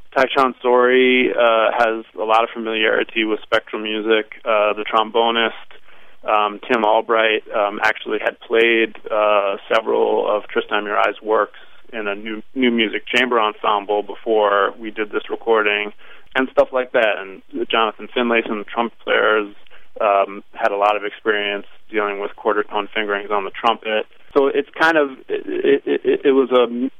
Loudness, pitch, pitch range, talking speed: -18 LUFS, 110 Hz, 105-125 Hz, 165 wpm